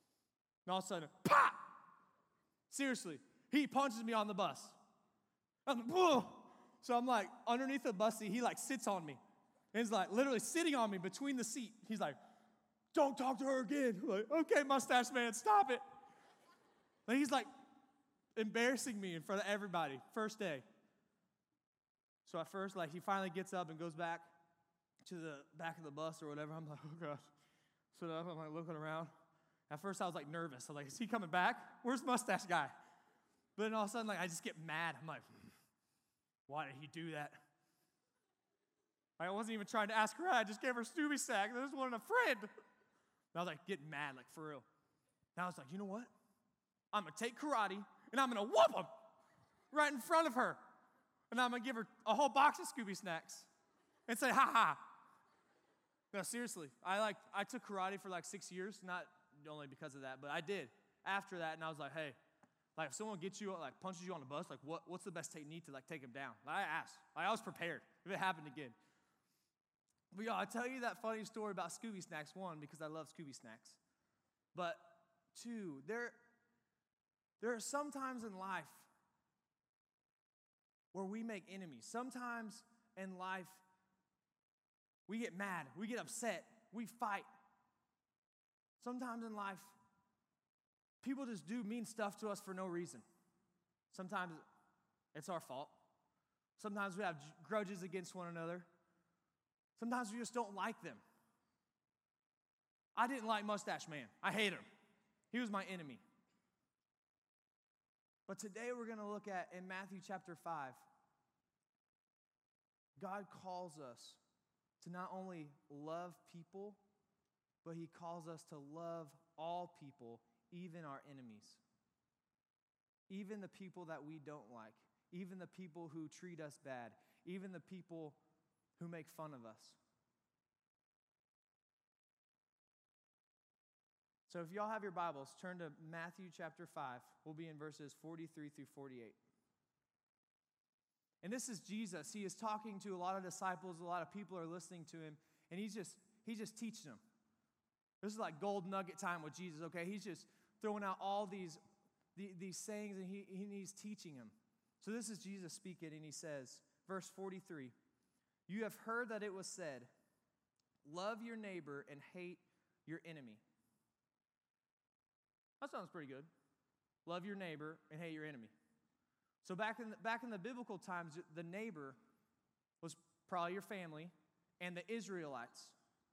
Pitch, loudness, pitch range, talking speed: 190 Hz, -43 LUFS, 165-220 Hz, 170 wpm